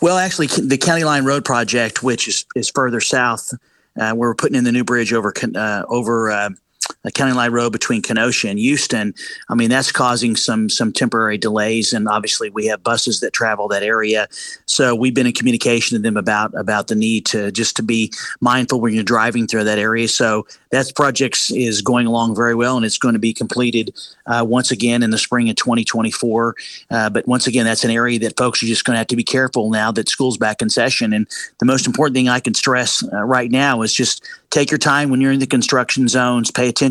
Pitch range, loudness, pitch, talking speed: 110-130 Hz, -16 LUFS, 120 Hz, 230 wpm